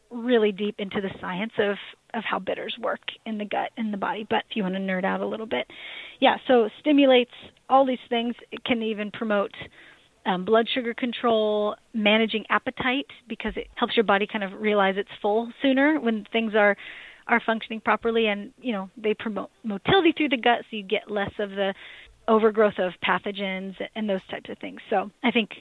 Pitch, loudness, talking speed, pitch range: 220 Hz, -25 LUFS, 200 wpm, 205-240 Hz